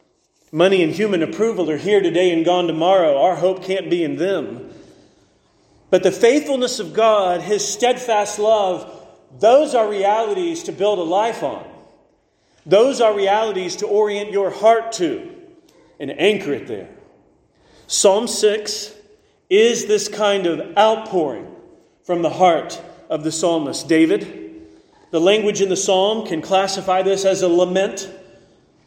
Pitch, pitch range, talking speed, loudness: 205 Hz, 185-225 Hz, 145 wpm, -18 LUFS